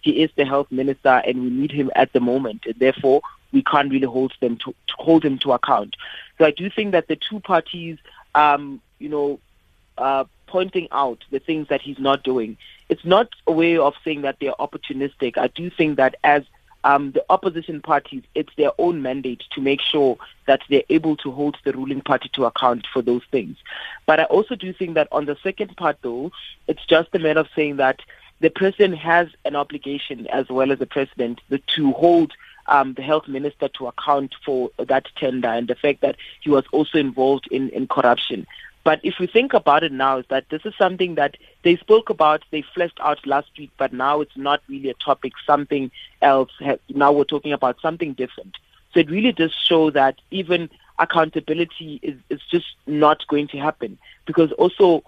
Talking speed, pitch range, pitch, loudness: 205 wpm, 135-165 Hz, 145 Hz, -20 LUFS